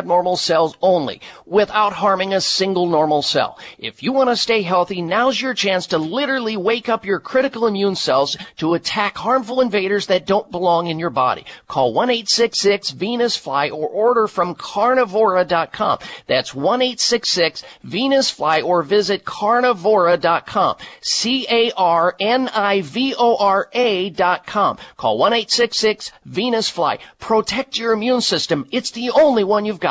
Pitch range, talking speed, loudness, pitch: 180-235 Hz, 140 wpm, -18 LUFS, 205 Hz